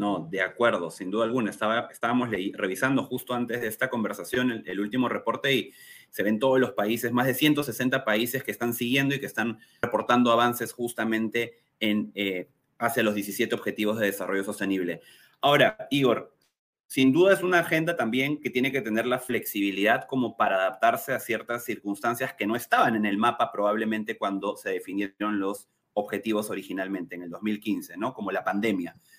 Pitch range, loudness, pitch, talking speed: 105-130 Hz, -26 LUFS, 115 Hz, 175 wpm